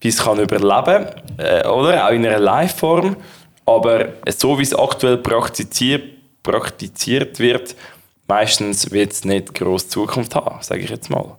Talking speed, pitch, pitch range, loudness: 150 wpm, 115 Hz, 105-135 Hz, -17 LUFS